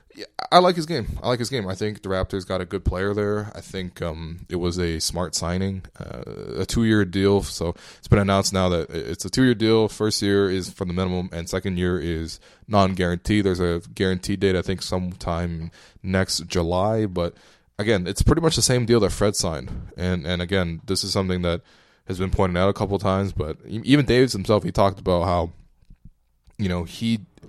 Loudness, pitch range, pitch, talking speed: -23 LUFS, 90-105 Hz, 95 Hz, 210 wpm